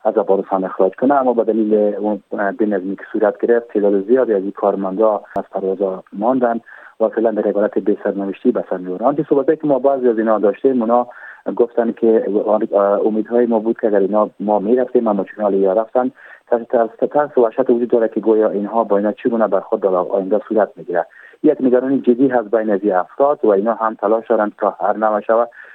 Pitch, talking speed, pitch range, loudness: 110 Hz, 195 wpm, 100-120 Hz, -17 LUFS